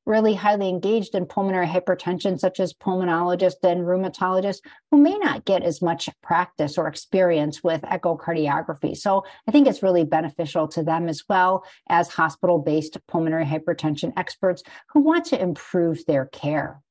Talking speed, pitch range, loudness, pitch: 155 wpm, 165-190 Hz, -22 LUFS, 180 Hz